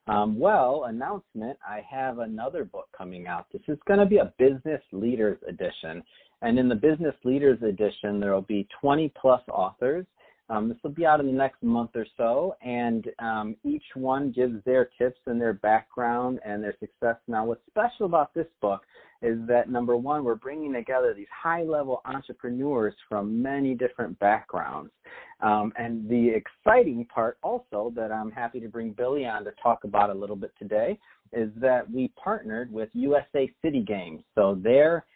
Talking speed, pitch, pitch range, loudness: 180 wpm, 125 Hz, 115-150 Hz, -27 LUFS